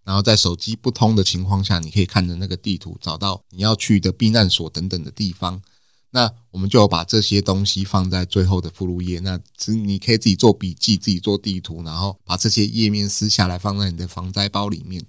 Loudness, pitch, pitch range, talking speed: -19 LUFS, 100 Hz, 90-105 Hz, 340 characters per minute